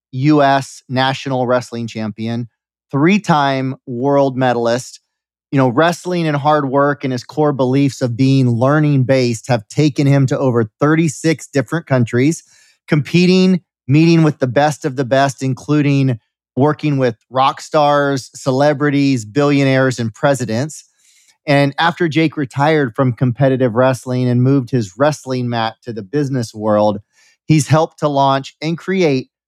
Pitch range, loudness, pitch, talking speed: 130-150 Hz, -15 LUFS, 140 Hz, 140 wpm